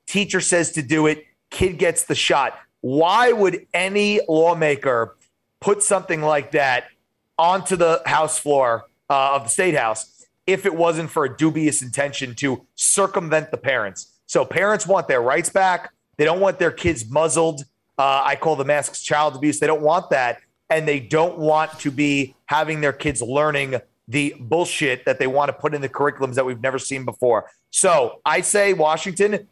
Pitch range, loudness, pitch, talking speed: 140-170 Hz, -20 LUFS, 155 Hz, 180 wpm